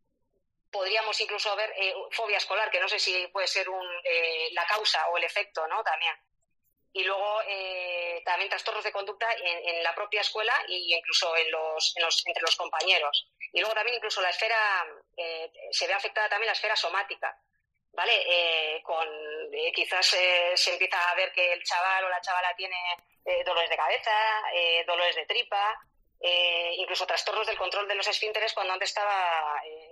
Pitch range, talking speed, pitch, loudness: 170-210 Hz, 185 wpm, 185 Hz, -27 LUFS